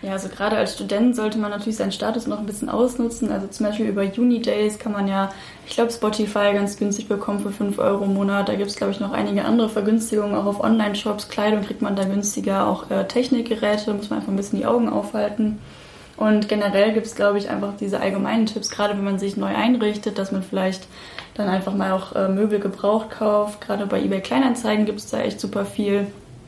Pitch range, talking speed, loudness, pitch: 200-220 Hz, 225 wpm, -22 LUFS, 210 Hz